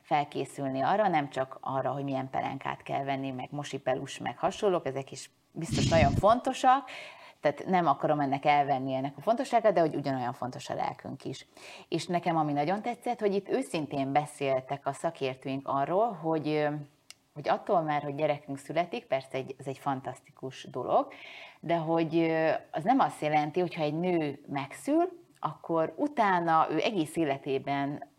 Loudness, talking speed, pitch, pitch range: -30 LUFS, 160 wpm, 150 Hz, 135-175 Hz